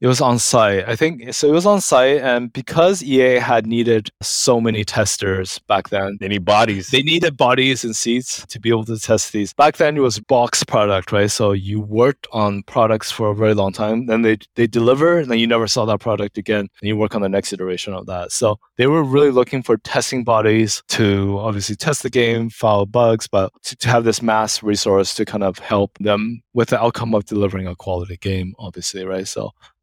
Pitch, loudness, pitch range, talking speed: 110 Hz, -17 LUFS, 100-120 Hz, 225 wpm